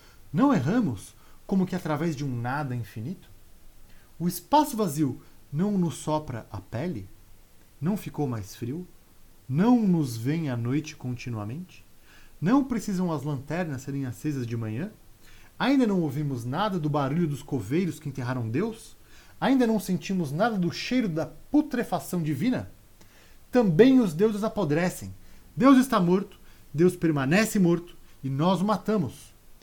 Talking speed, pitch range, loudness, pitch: 140 wpm, 125-195 Hz, -26 LUFS, 155 Hz